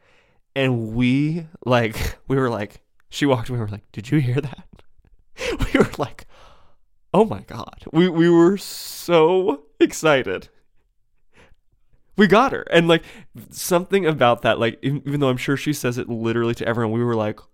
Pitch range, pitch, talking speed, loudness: 115-170 Hz, 135 Hz, 170 wpm, -20 LUFS